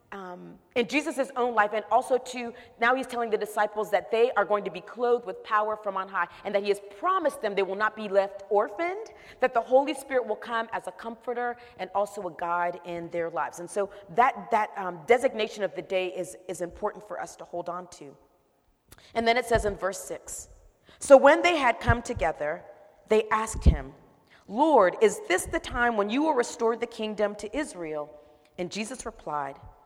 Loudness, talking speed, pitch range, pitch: -27 LUFS, 205 wpm, 185-240 Hz, 215 Hz